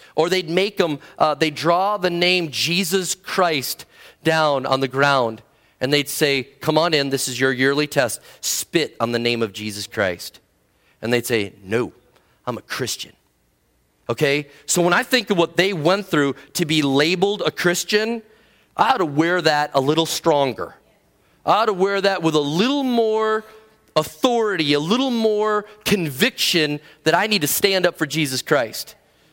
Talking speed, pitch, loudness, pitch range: 175 wpm, 160 Hz, -20 LUFS, 140-195 Hz